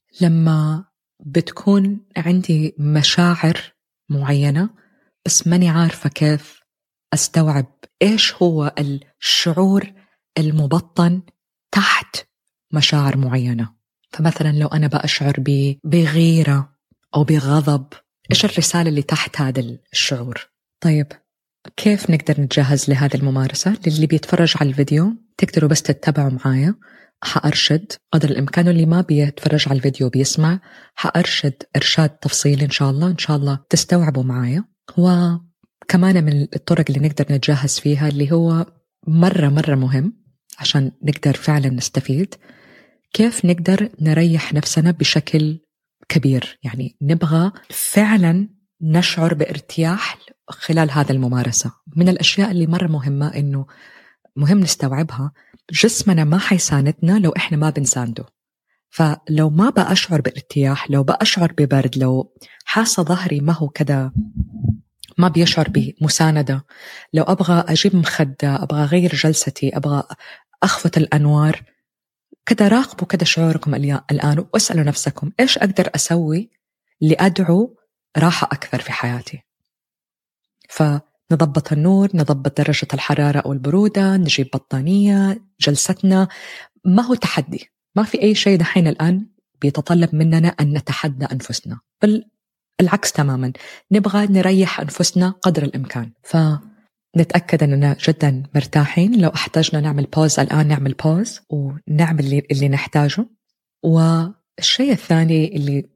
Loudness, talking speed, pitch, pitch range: -17 LUFS, 115 wpm, 155 Hz, 145-180 Hz